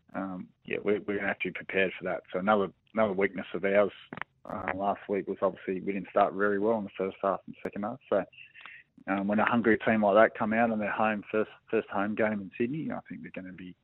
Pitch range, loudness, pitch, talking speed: 95-110 Hz, -29 LUFS, 100 Hz, 250 wpm